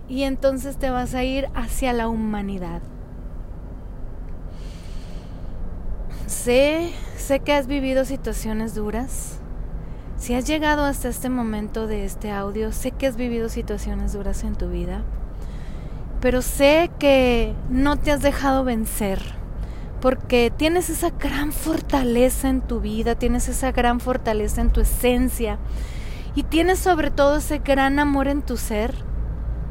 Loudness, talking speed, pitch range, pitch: -22 LUFS, 135 wpm, 210-275 Hz, 245 Hz